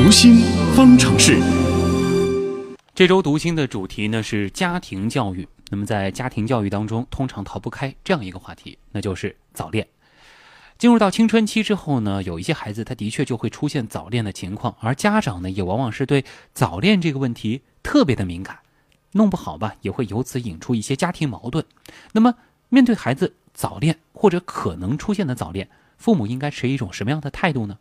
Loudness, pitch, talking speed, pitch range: -19 LUFS, 130 Hz, 295 characters per minute, 105-175 Hz